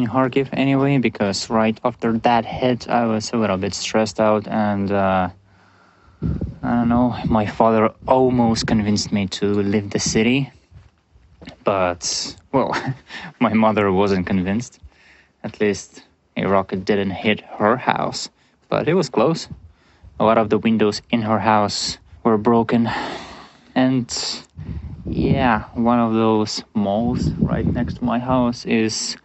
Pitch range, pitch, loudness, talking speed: 100-120 Hz, 110 Hz, -19 LUFS, 140 wpm